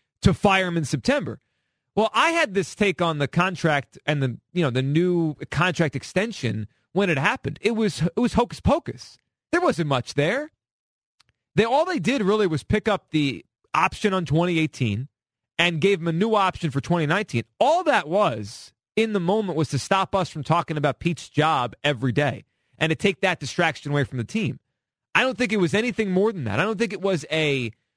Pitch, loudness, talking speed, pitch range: 165 Hz, -23 LUFS, 205 wpm, 140-200 Hz